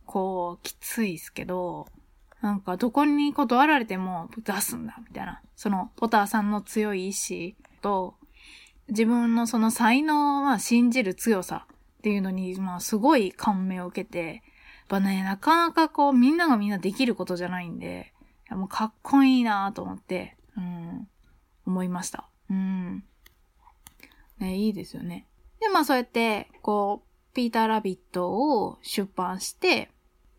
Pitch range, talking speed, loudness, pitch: 185-245 Hz, 300 characters per minute, -26 LUFS, 210 Hz